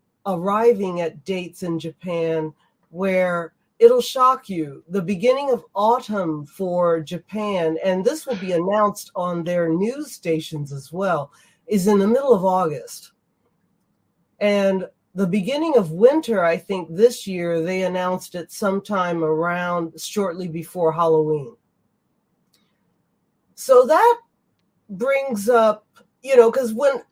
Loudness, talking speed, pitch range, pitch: -20 LUFS, 125 wpm, 170-230 Hz, 195 Hz